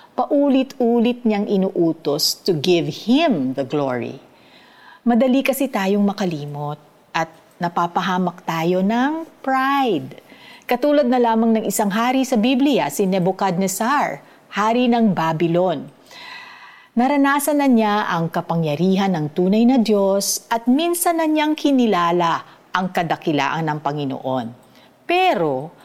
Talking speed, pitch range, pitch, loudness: 115 wpm, 170-260 Hz, 205 Hz, -19 LUFS